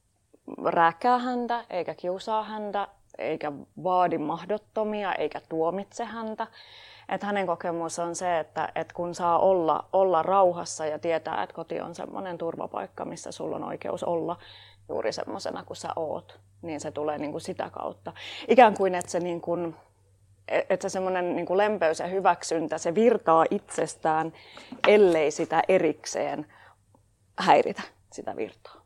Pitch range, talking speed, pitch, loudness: 155-195 Hz, 135 wpm, 170 Hz, -27 LUFS